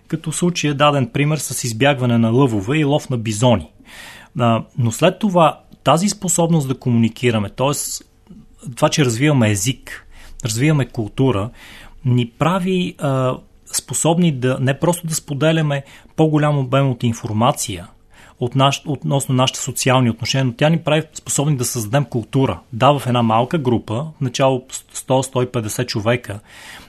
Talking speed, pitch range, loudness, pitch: 140 wpm, 120-150 Hz, -18 LUFS, 130 Hz